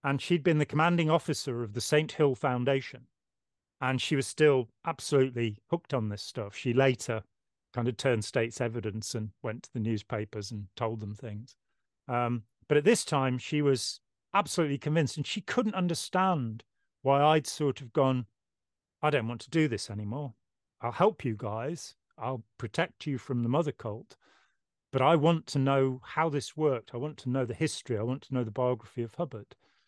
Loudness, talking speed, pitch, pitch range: -30 LUFS, 190 wpm, 130 Hz, 115-150 Hz